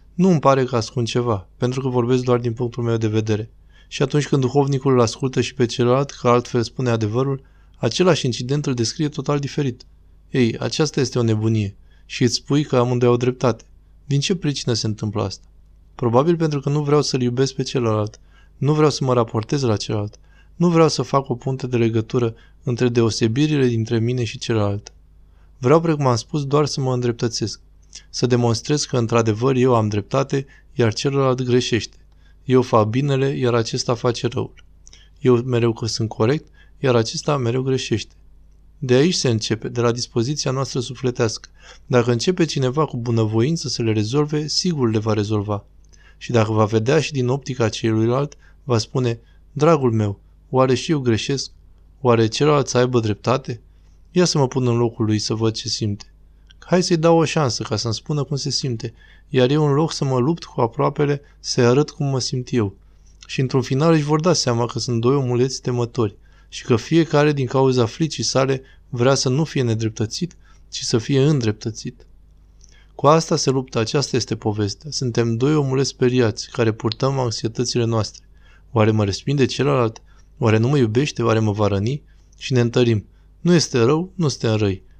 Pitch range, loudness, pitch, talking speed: 110-135 Hz, -20 LUFS, 120 Hz, 185 wpm